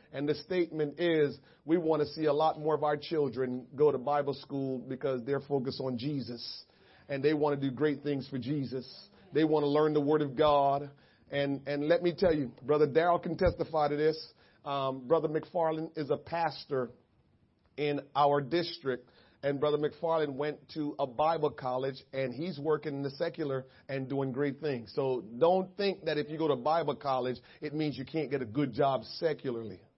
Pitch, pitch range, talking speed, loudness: 145 Hz, 135-155 Hz, 195 wpm, -32 LUFS